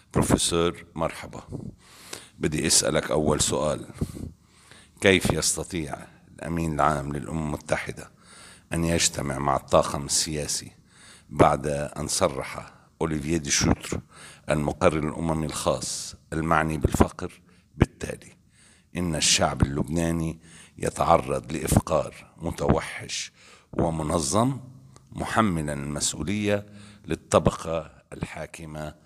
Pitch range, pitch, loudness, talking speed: 75-90 Hz, 80 Hz, -25 LUFS, 85 wpm